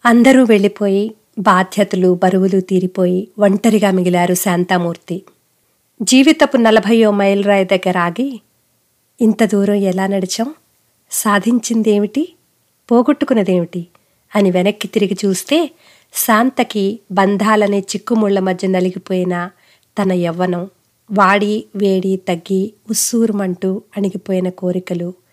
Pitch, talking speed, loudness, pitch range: 200 Hz, 90 wpm, -15 LUFS, 185-220 Hz